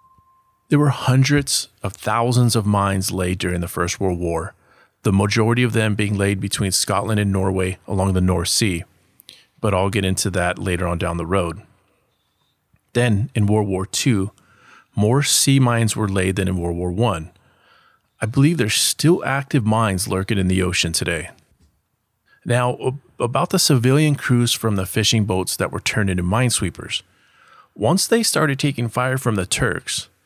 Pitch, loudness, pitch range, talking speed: 105 Hz, -19 LUFS, 95-125 Hz, 170 wpm